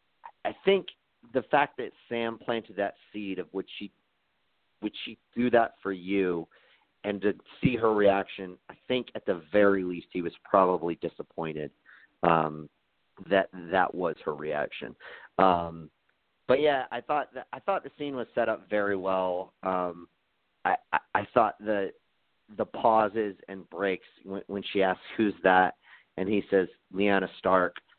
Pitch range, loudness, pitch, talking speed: 90-105 Hz, -29 LUFS, 95 Hz, 160 wpm